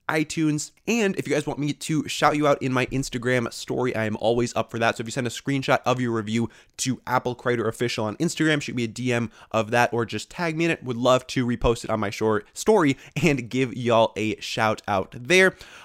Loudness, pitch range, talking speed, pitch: -24 LUFS, 115-145 Hz, 240 wpm, 125 Hz